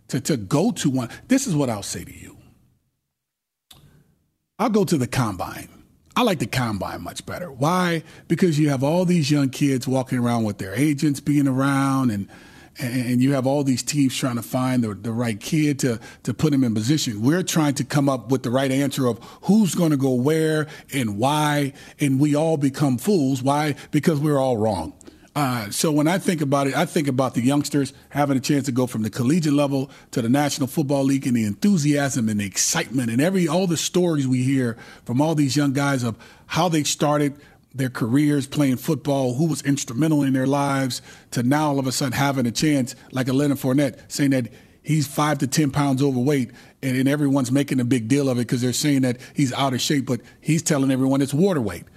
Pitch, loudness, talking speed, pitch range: 140 Hz, -21 LUFS, 215 wpm, 130-150 Hz